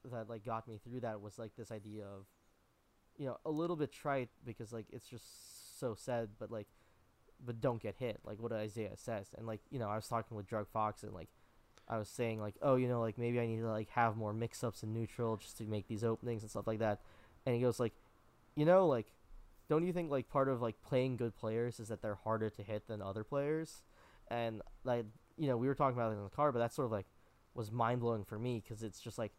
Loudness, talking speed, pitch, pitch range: -39 LUFS, 250 wpm, 115 Hz, 110-120 Hz